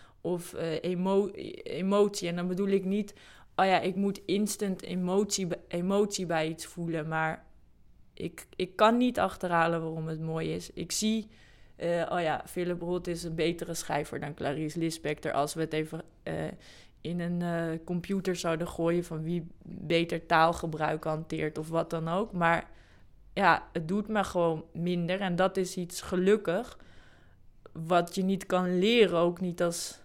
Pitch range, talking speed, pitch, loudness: 160-185 Hz, 165 wpm, 170 Hz, -30 LUFS